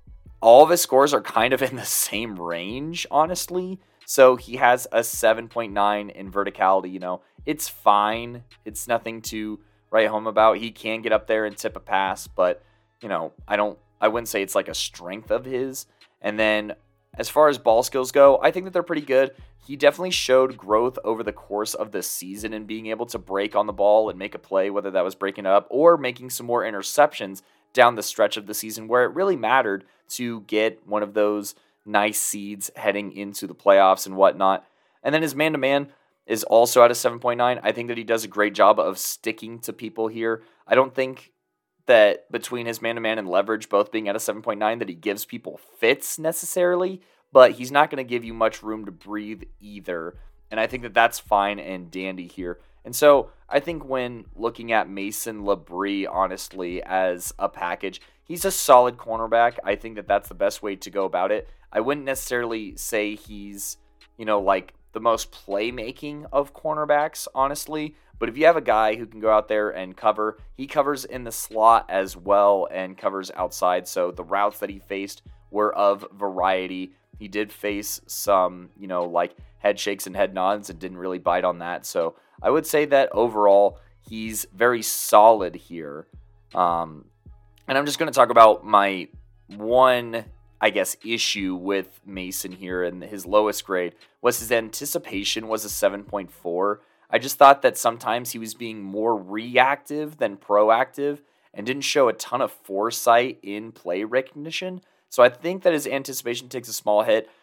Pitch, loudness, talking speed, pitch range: 110 Hz, -22 LUFS, 195 wpm, 100-125 Hz